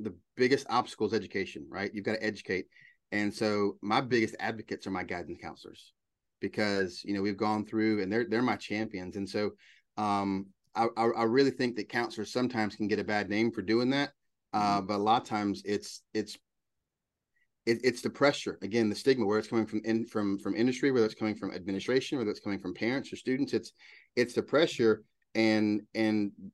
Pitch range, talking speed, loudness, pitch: 100-115 Hz, 205 wpm, -31 LUFS, 110 Hz